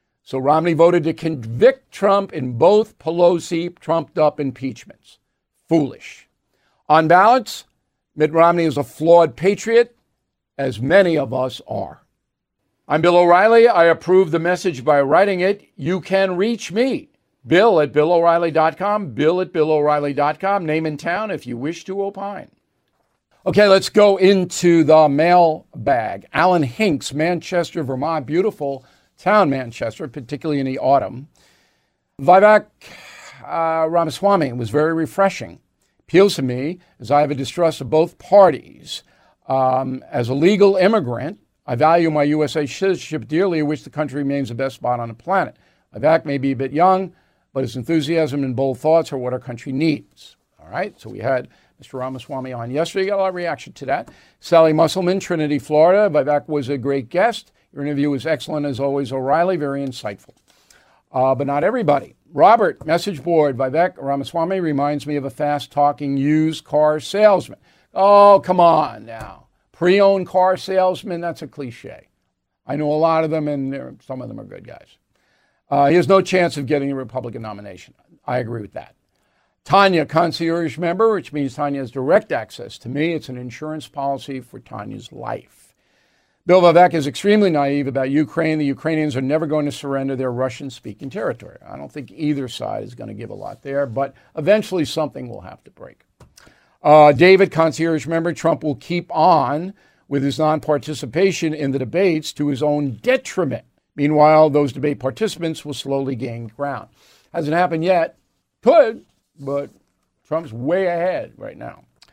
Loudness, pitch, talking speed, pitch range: -18 LUFS, 155 Hz, 165 wpm, 140-175 Hz